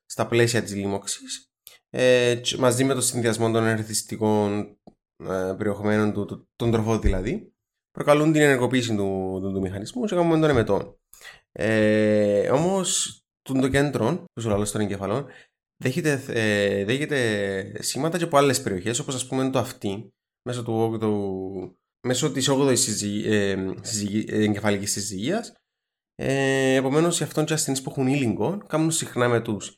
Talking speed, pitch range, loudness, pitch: 135 wpm, 105-135 Hz, -23 LUFS, 115 Hz